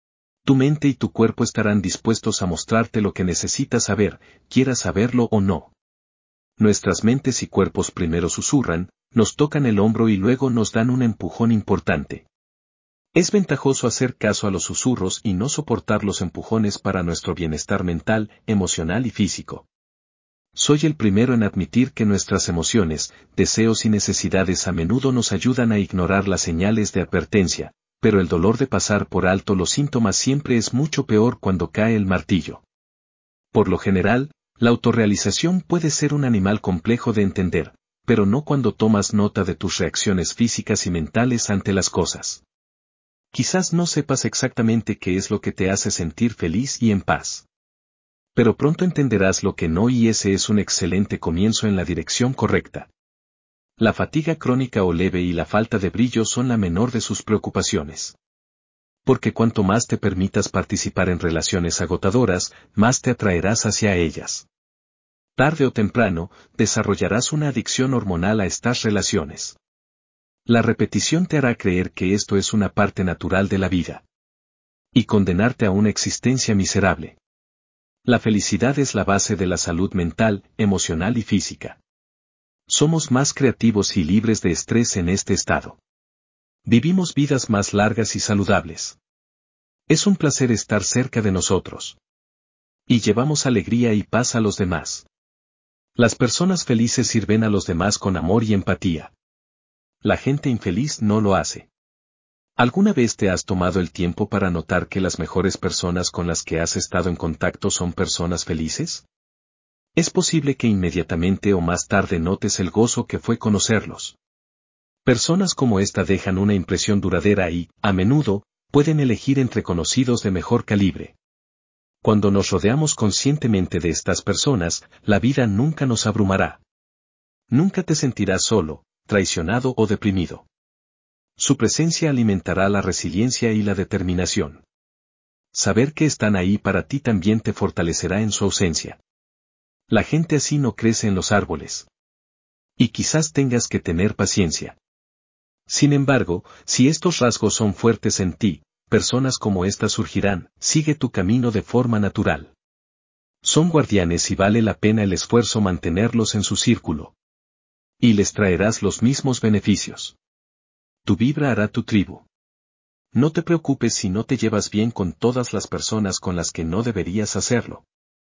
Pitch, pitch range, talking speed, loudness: 105 Hz, 90-120 Hz, 155 wpm, -20 LUFS